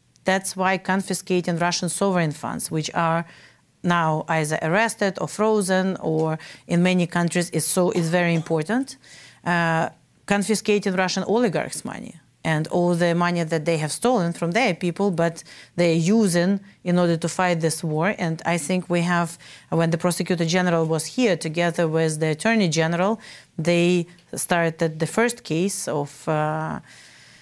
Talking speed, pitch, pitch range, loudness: 155 wpm, 175 Hz, 165-190 Hz, -22 LUFS